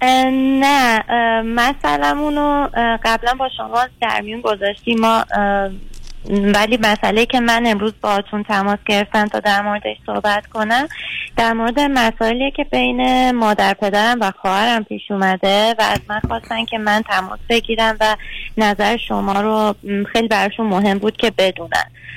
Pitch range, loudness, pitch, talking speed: 205-235 Hz, -16 LUFS, 220 Hz, 145 wpm